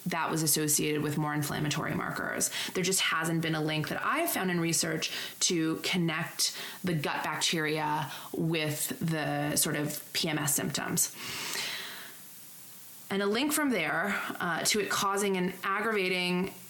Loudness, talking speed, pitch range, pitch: -30 LUFS, 145 wpm, 155-185 Hz, 165 Hz